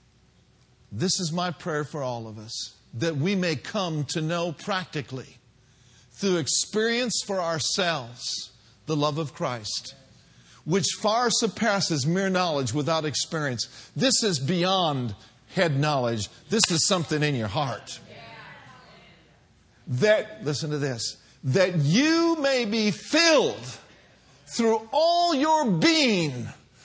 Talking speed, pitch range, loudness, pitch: 120 wpm, 130-195 Hz, -25 LUFS, 160 Hz